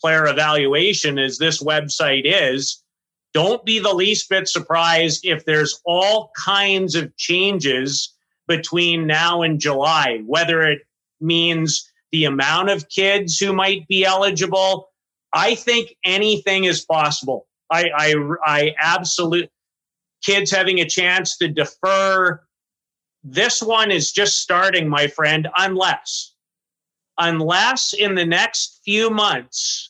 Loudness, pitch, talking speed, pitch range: -17 LUFS, 175 Hz, 125 wpm, 155-195 Hz